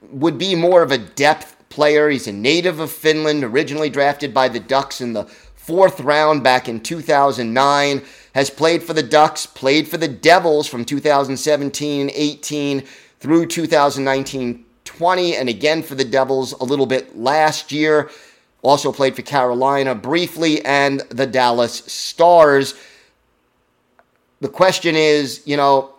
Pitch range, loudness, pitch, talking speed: 135-155 Hz, -16 LUFS, 140 Hz, 145 wpm